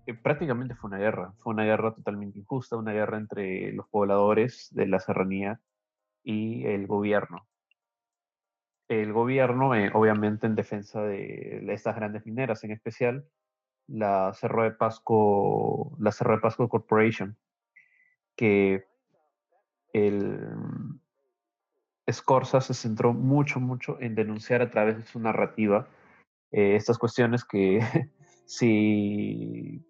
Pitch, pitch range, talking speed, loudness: 110 Hz, 105-120 Hz, 120 wpm, -27 LUFS